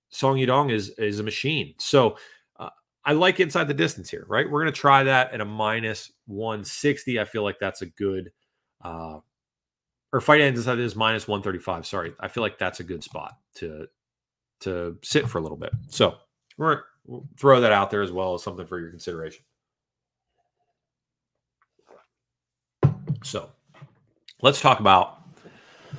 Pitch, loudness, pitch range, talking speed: 110 Hz, -23 LUFS, 95-140 Hz, 165 wpm